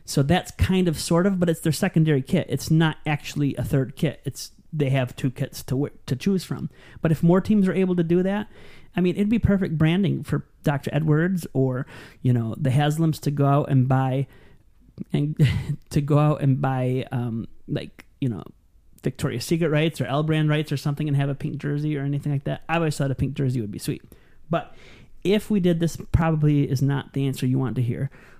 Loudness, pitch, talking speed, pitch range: -23 LUFS, 145 Hz, 225 wpm, 135-165 Hz